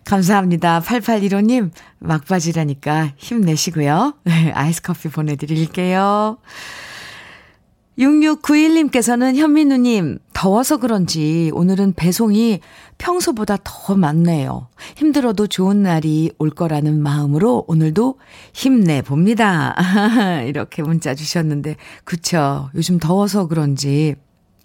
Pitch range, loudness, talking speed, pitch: 155-220 Hz, -16 LUFS, 240 characters per minute, 175 Hz